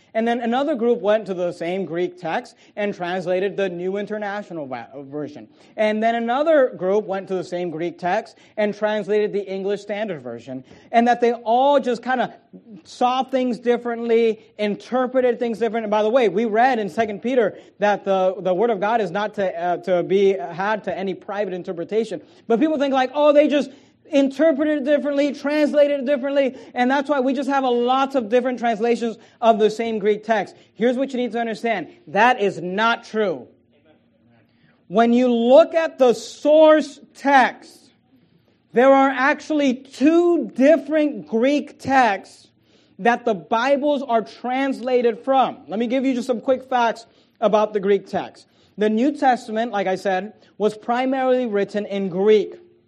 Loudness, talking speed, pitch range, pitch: -20 LUFS, 175 wpm, 205-265 Hz, 235 Hz